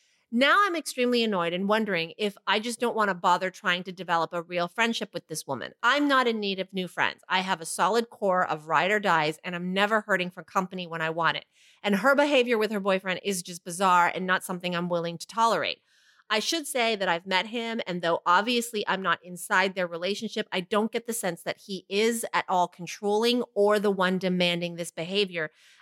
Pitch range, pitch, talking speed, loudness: 175-220 Hz, 190 Hz, 225 wpm, -26 LUFS